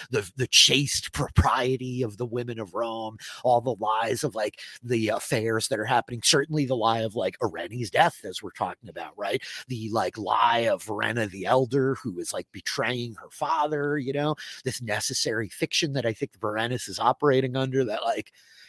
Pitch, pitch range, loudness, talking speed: 120 Hz, 110-135 Hz, -26 LUFS, 185 wpm